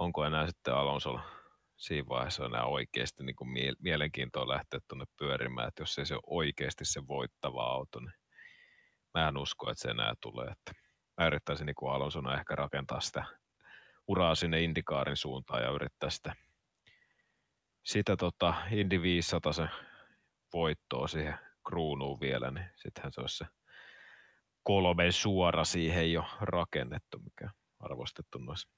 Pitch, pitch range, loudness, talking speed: 80 Hz, 70-85 Hz, -34 LUFS, 140 wpm